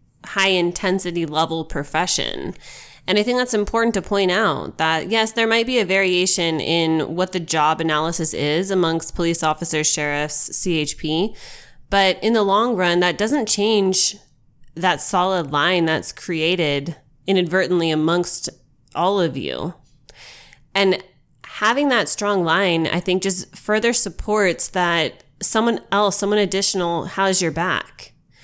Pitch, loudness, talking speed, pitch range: 180 Hz, -19 LUFS, 140 wpm, 160-195 Hz